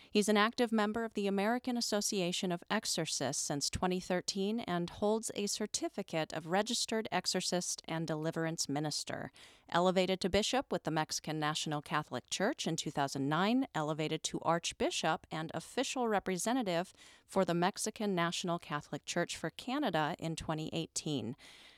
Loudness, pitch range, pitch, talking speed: -35 LUFS, 160-210 Hz, 180 Hz, 135 wpm